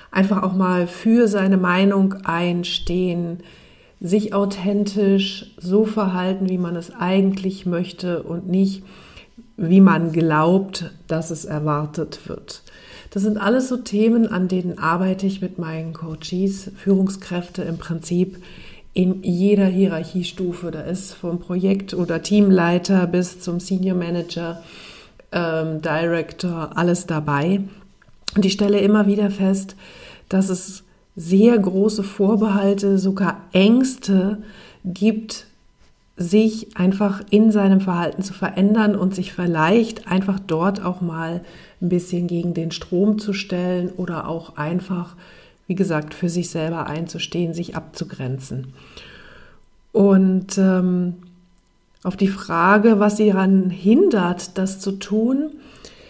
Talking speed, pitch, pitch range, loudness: 125 wpm, 185 Hz, 175-200 Hz, -20 LUFS